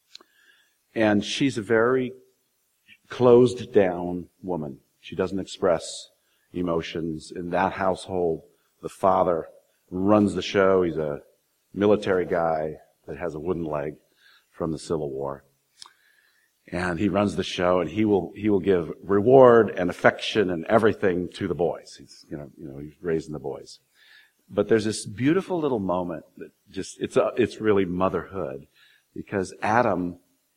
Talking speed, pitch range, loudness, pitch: 145 wpm, 85-110 Hz, -24 LUFS, 95 Hz